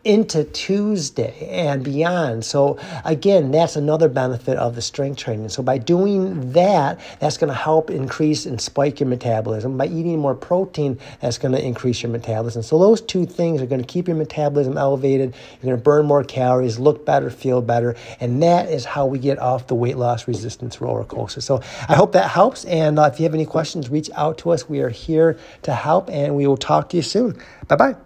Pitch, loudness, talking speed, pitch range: 140 Hz, -19 LUFS, 210 wpm, 125-160 Hz